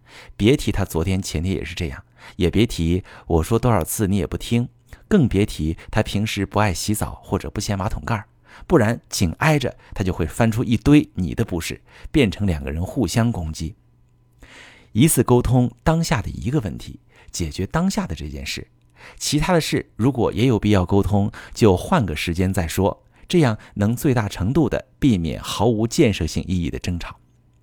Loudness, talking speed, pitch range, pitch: -21 LUFS, 270 characters per minute, 85-120 Hz, 100 Hz